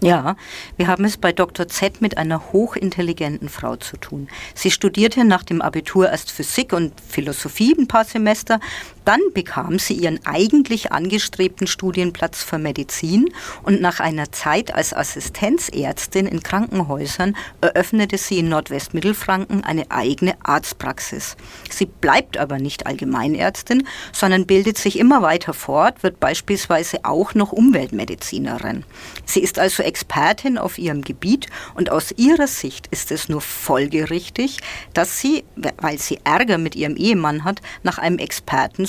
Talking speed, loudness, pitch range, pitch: 140 wpm, -19 LUFS, 165-215 Hz, 185 Hz